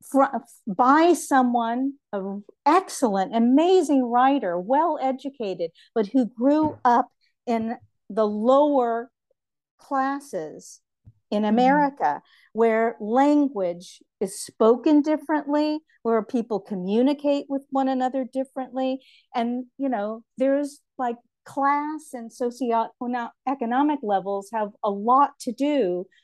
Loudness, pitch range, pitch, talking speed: -23 LUFS, 225-280 Hz, 255 Hz, 105 wpm